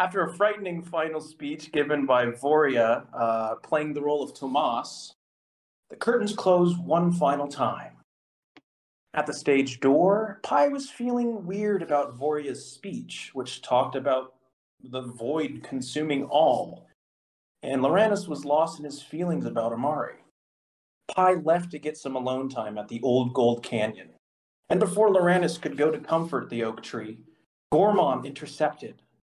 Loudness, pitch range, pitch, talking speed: -26 LUFS, 120-175 Hz, 145 Hz, 145 wpm